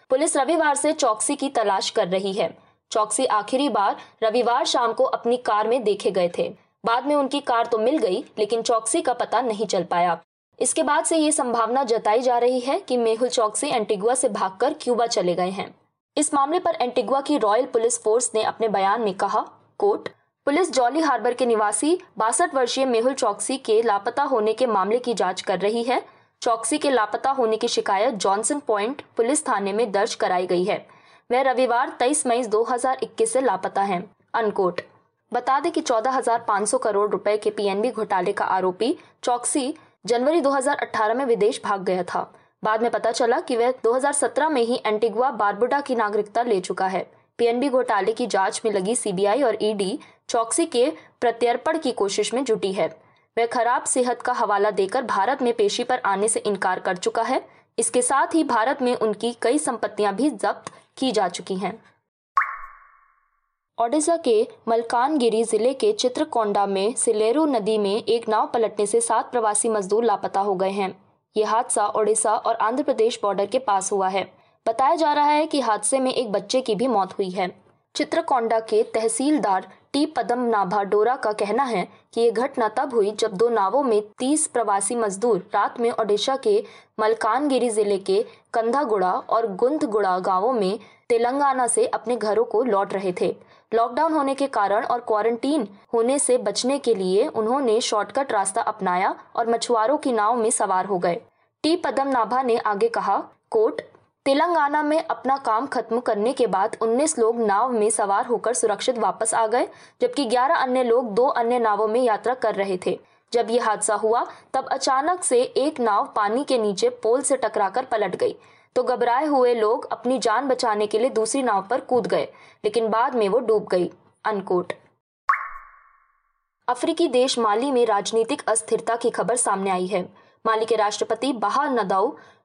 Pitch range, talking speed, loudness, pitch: 210-265 Hz, 175 wpm, -22 LUFS, 235 Hz